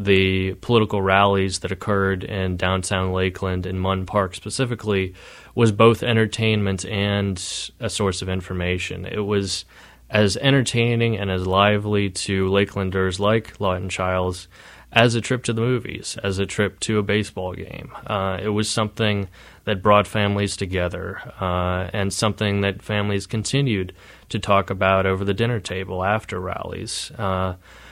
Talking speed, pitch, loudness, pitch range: 150 wpm, 100 Hz, -22 LUFS, 95-110 Hz